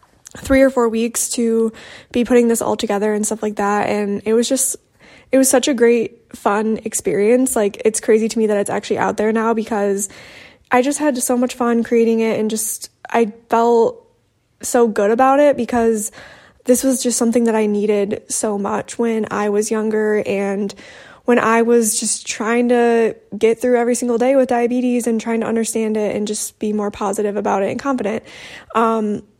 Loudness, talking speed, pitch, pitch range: -17 LUFS, 195 wpm, 230 Hz, 215-245 Hz